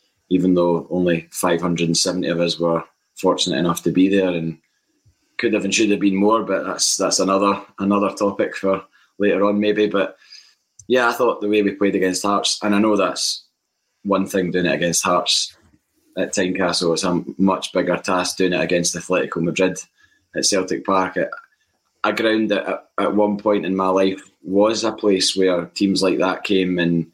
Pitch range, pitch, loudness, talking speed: 90-100 Hz, 95 Hz, -19 LUFS, 185 wpm